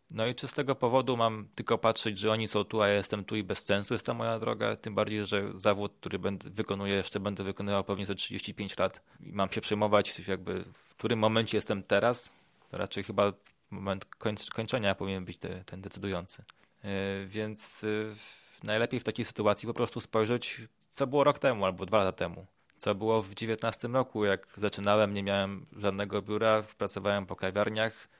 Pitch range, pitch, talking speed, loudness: 100-115 Hz, 105 Hz, 190 wpm, -31 LUFS